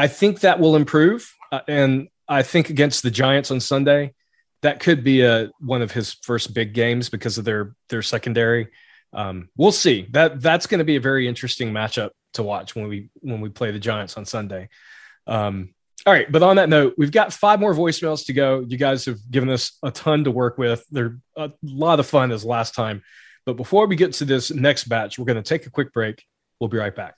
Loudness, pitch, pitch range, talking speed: -20 LUFS, 130 Hz, 115-150 Hz, 225 wpm